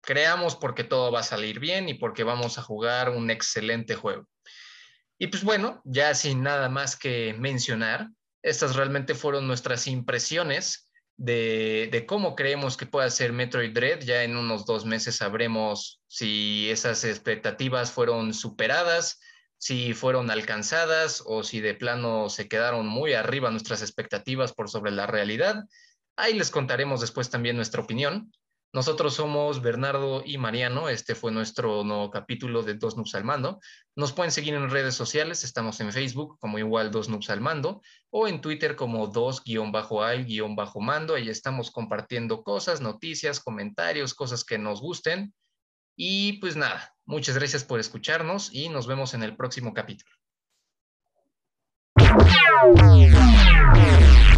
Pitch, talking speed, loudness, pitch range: 125 Hz, 150 wpm, -24 LUFS, 110-145 Hz